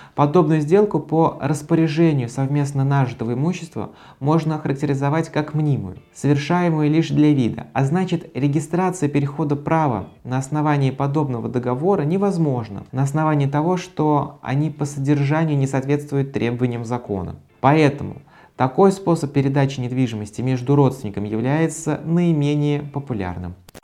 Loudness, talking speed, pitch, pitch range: -20 LUFS, 115 wpm, 145 Hz, 130-155 Hz